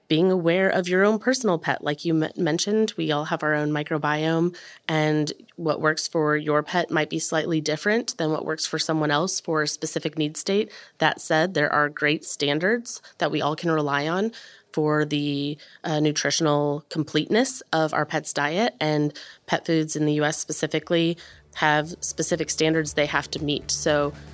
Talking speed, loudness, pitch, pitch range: 180 wpm, -24 LUFS, 155 Hz, 150-170 Hz